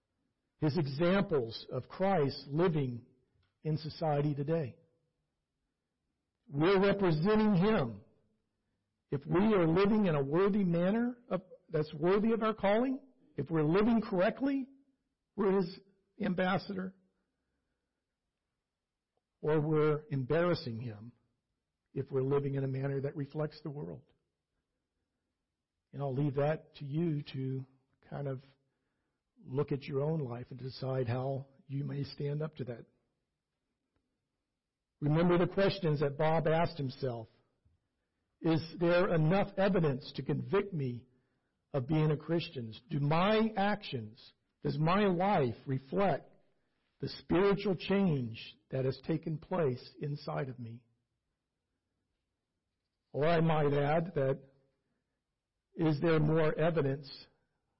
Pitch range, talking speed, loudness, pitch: 130-175 Hz, 115 wpm, -33 LUFS, 150 Hz